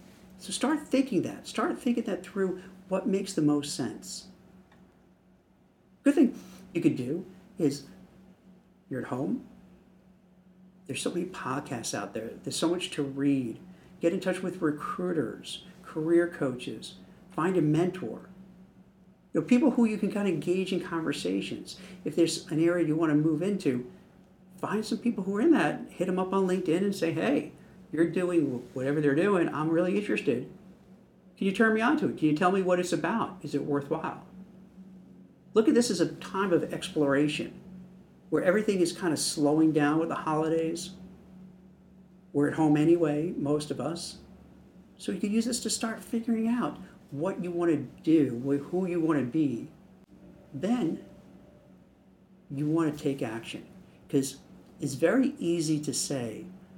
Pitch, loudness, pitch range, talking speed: 180 Hz, -29 LUFS, 155-195 Hz, 170 wpm